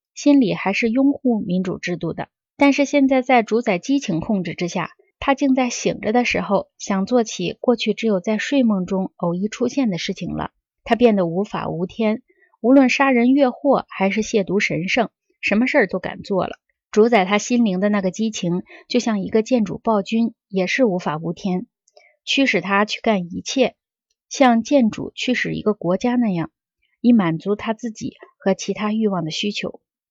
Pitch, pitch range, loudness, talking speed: 220 Hz, 190-250 Hz, -20 LUFS, 265 characters per minute